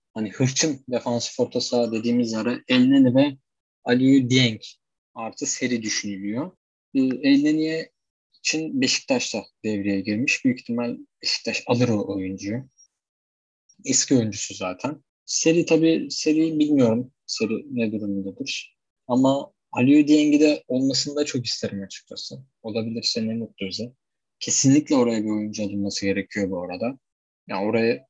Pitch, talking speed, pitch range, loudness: 125 Hz, 125 wpm, 110-135 Hz, -22 LUFS